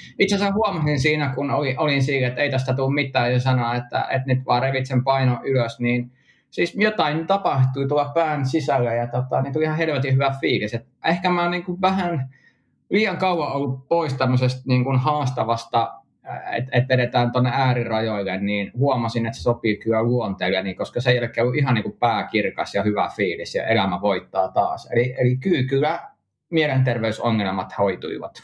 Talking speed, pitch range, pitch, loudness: 175 wpm, 120-145 Hz, 130 Hz, -21 LUFS